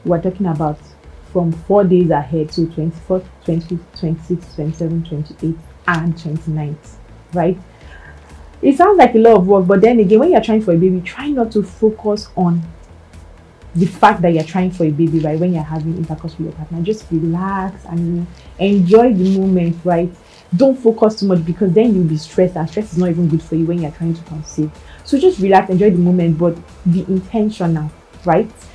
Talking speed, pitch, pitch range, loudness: 195 wpm, 175 Hz, 160-195 Hz, -15 LUFS